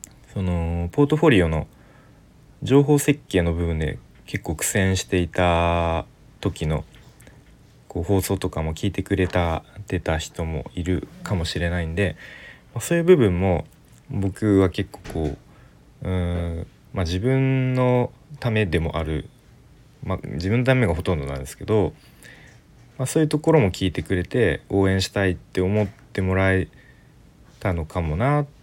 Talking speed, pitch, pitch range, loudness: 275 characters per minute, 95 Hz, 85-115 Hz, -23 LUFS